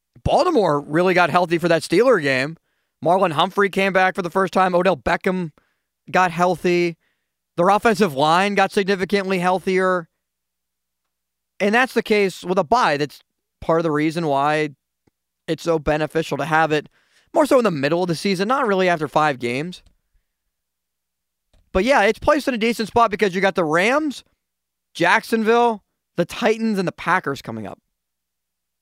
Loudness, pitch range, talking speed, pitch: -19 LUFS, 150-200 Hz, 165 wpm, 180 Hz